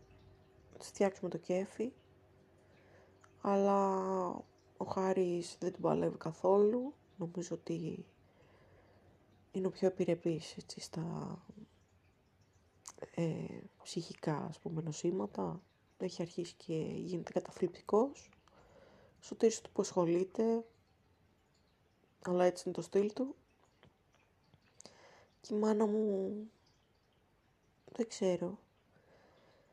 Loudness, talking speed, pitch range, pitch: -37 LUFS, 90 wpm, 170-205 Hz, 185 Hz